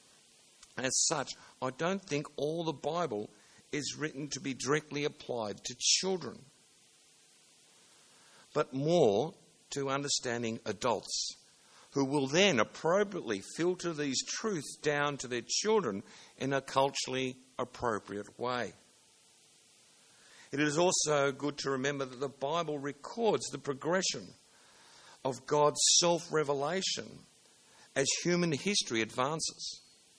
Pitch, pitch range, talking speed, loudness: 145 Hz, 135-165 Hz, 115 wpm, -32 LUFS